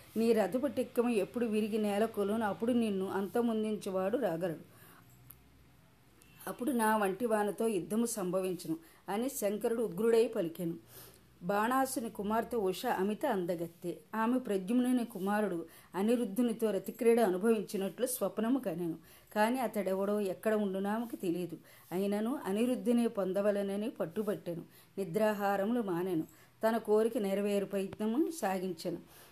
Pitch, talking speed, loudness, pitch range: 210 Hz, 100 wpm, -34 LUFS, 190-230 Hz